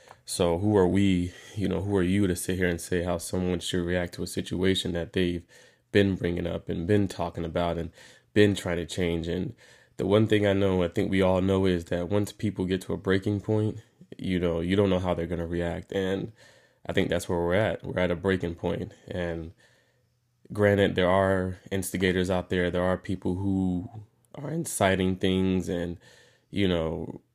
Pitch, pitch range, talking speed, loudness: 95 Hz, 85-100 Hz, 205 wpm, -27 LUFS